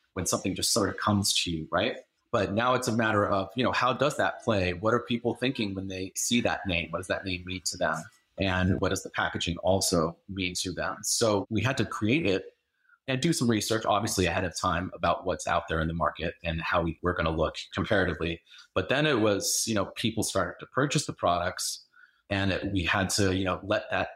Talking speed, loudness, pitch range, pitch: 240 wpm, -28 LUFS, 90-115 Hz, 95 Hz